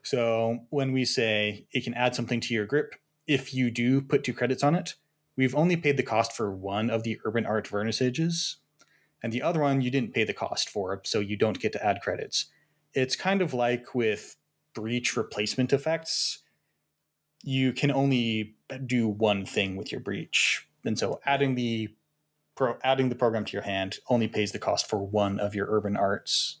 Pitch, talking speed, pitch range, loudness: 120 Hz, 190 wpm, 110-135 Hz, -28 LUFS